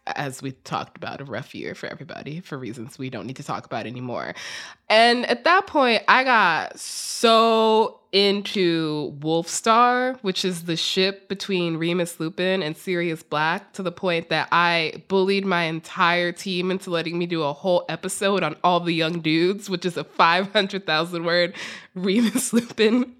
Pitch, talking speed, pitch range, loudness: 175 Hz, 170 wpm, 160-195 Hz, -22 LUFS